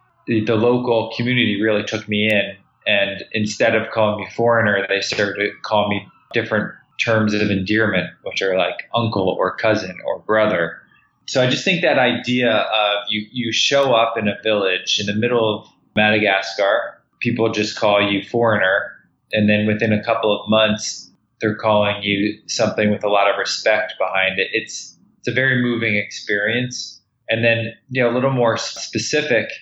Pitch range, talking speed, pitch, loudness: 105-120 Hz, 175 wpm, 110 Hz, -18 LUFS